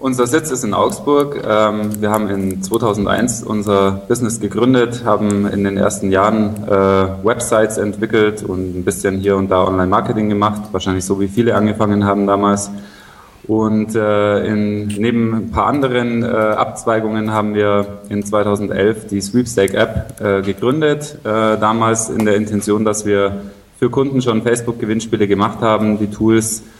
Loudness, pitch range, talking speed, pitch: -16 LUFS, 100-110 Hz, 140 wpm, 105 Hz